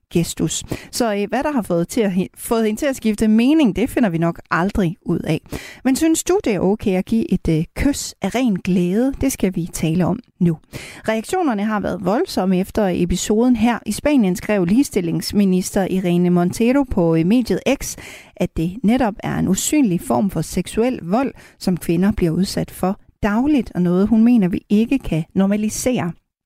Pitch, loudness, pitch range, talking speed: 205 Hz, -19 LUFS, 180-240 Hz, 180 wpm